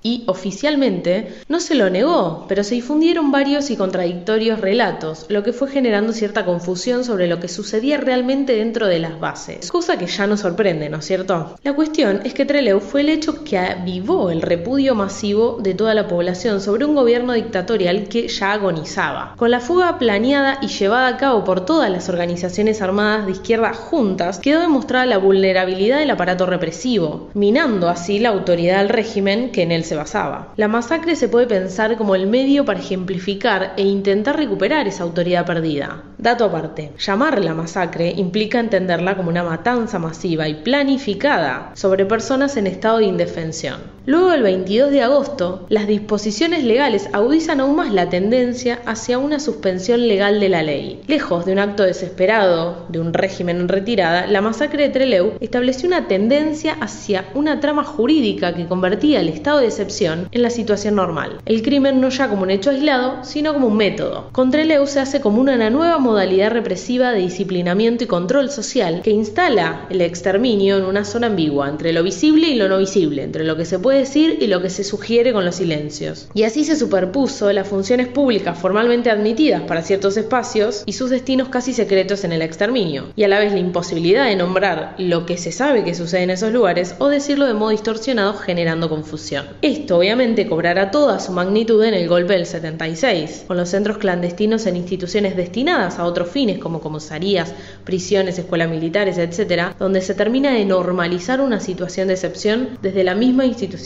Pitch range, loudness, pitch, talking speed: 185-250 Hz, -18 LUFS, 205 Hz, 185 wpm